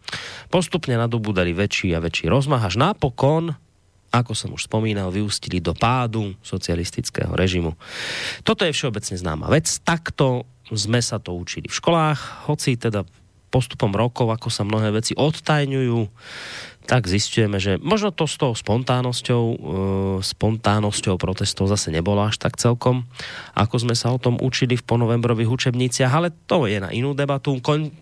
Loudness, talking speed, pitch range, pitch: -21 LUFS, 150 wpm, 100-130 Hz, 115 Hz